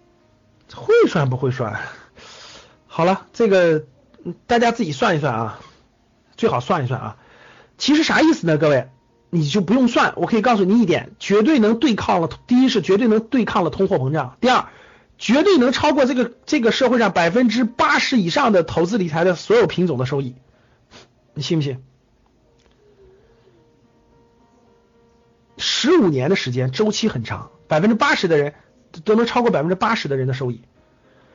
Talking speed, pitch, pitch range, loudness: 250 characters per minute, 185 Hz, 140-235 Hz, -18 LUFS